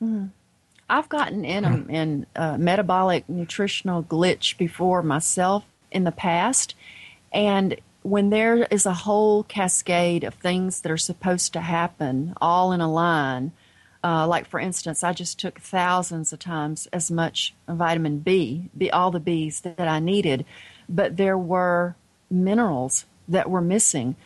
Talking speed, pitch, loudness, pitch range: 150 wpm, 175 Hz, -23 LUFS, 160-185 Hz